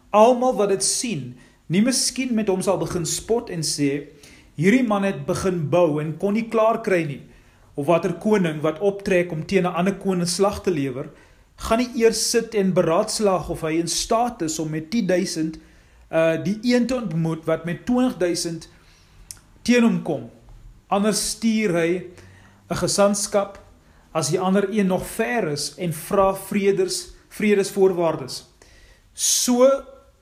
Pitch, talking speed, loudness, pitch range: 180 Hz, 155 wpm, -21 LUFS, 160-210 Hz